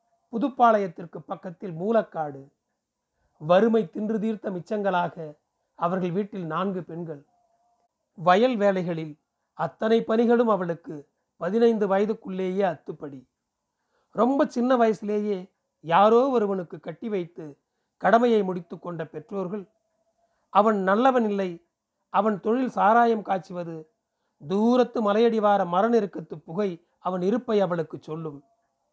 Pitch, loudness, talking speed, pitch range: 195 Hz, -24 LUFS, 95 wpm, 175-225 Hz